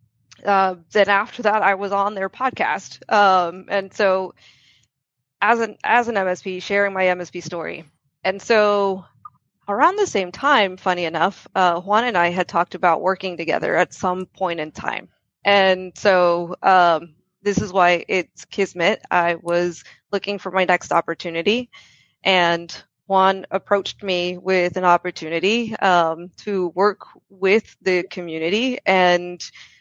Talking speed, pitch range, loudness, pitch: 145 wpm, 175-200 Hz, -19 LUFS, 185 Hz